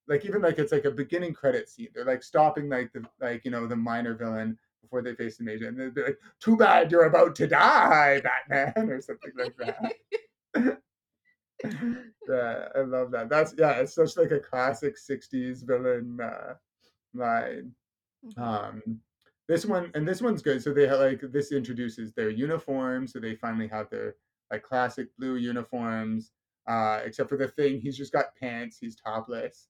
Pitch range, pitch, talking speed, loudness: 120-165 Hz, 130 Hz, 180 wpm, -27 LUFS